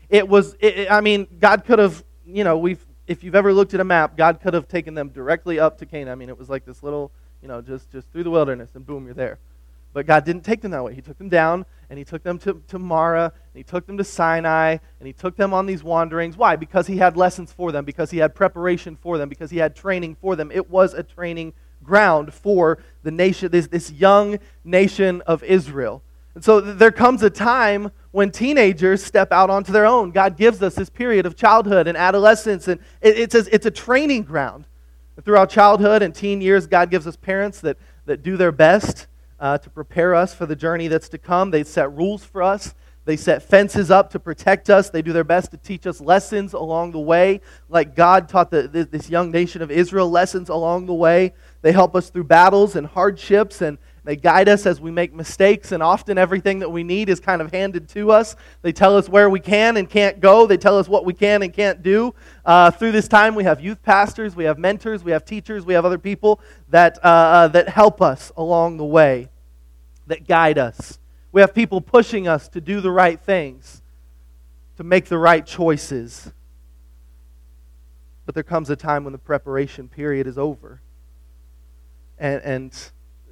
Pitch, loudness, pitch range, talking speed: 175 Hz, -17 LUFS, 155-195 Hz, 215 wpm